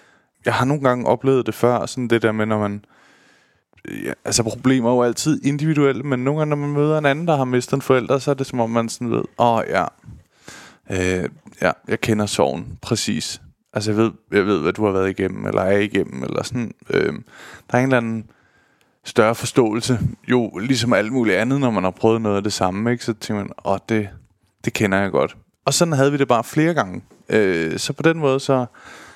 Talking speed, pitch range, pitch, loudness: 230 wpm, 105-135 Hz, 120 Hz, -20 LUFS